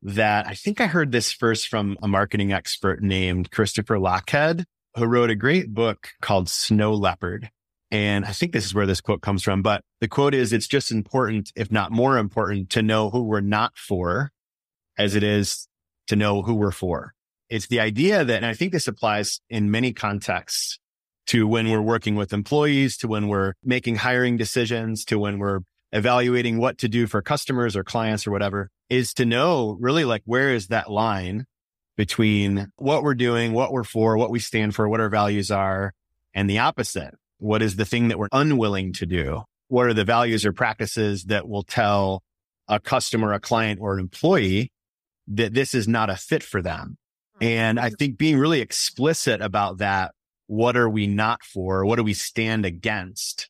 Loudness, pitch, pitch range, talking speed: -22 LUFS, 110 Hz, 100-120 Hz, 195 wpm